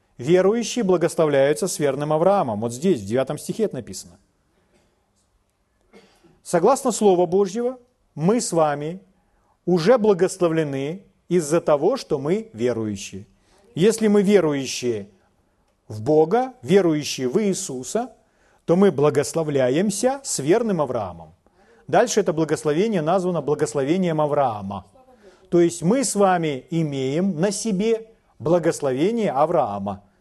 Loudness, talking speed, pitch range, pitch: -21 LUFS, 110 wpm, 130-200 Hz, 165 Hz